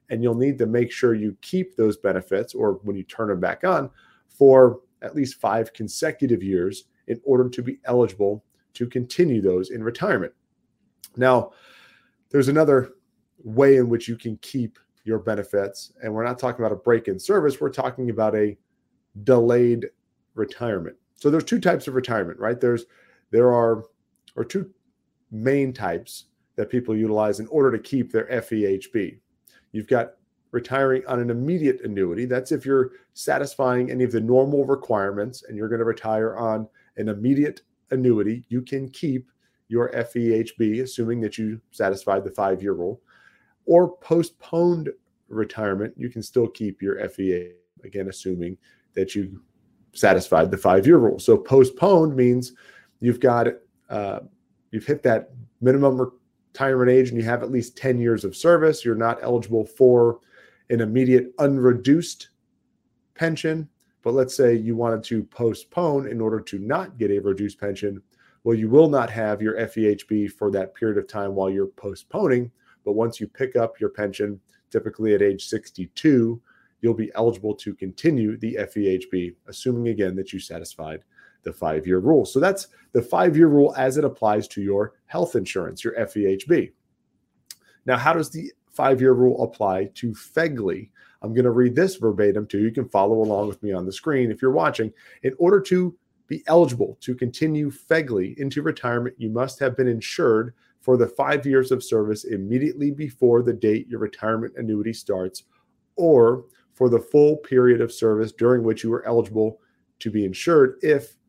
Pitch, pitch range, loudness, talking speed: 120 Hz, 110-130 Hz, -22 LUFS, 170 wpm